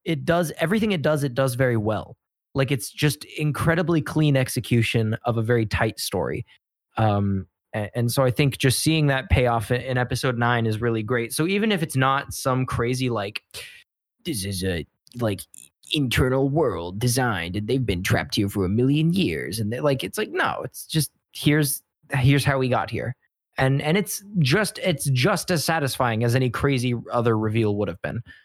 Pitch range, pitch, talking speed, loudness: 110-145 Hz, 130 Hz, 190 wpm, -23 LUFS